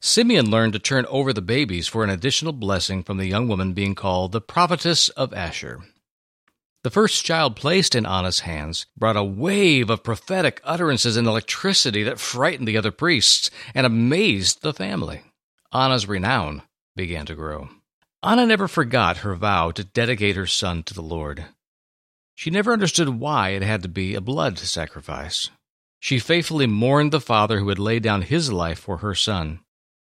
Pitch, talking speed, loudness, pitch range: 110 Hz, 175 wpm, -21 LUFS, 95-135 Hz